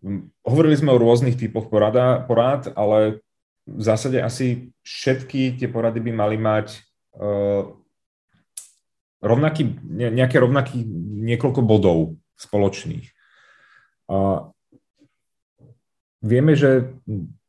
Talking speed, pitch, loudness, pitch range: 80 wpm, 115 Hz, -20 LUFS, 105-130 Hz